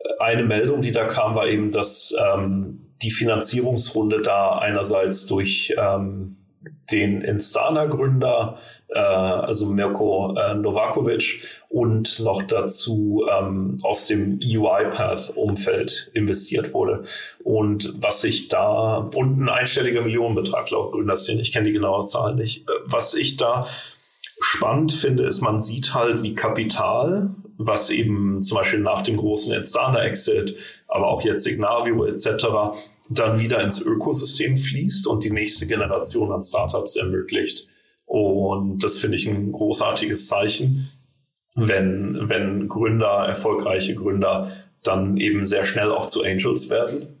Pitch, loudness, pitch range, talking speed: 110 Hz, -21 LUFS, 100-120 Hz, 135 wpm